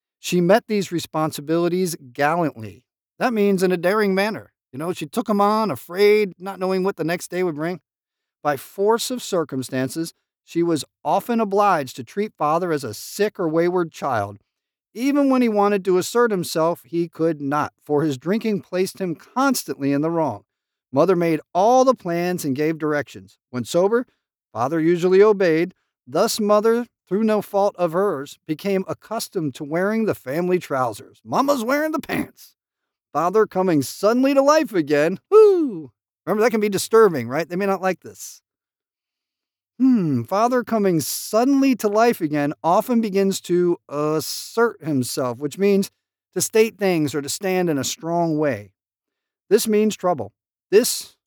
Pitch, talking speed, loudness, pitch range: 180 Hz, 165 wpm, -21 LUFS, 150-210 Hz